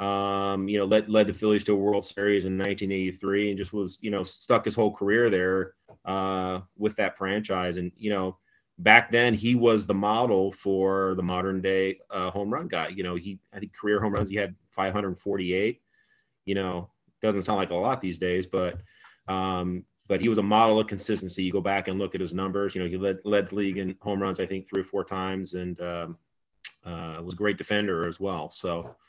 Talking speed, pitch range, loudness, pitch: 220 wpm, 95-100 Hz, -27 LUFS, 95 Hz